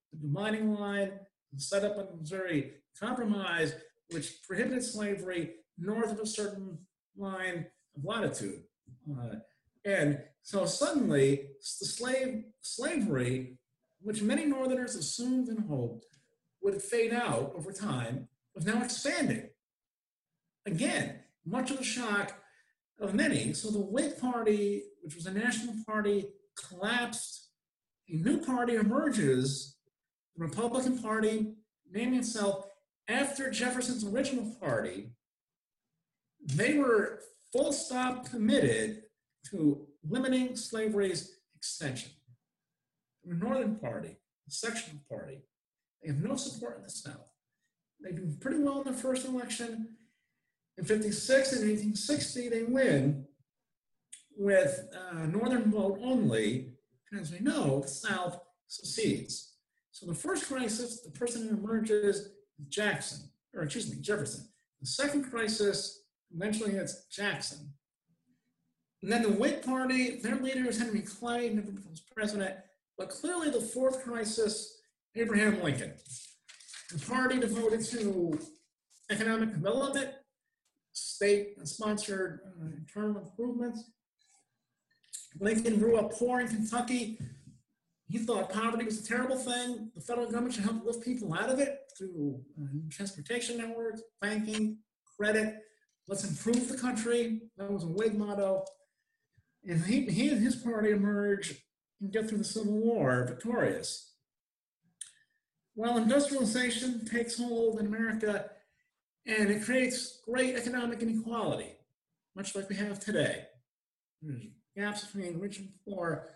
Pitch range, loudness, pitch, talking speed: 180-245 Hz, -33 LUFS, 215 Hz, 125 wpm